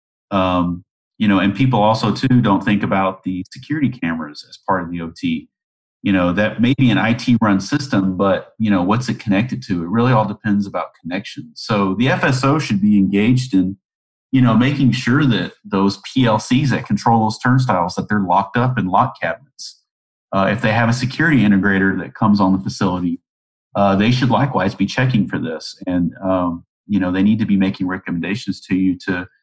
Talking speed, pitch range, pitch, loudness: 200 wpm, 95-120 Hz, 105 Hz, -17 LUFS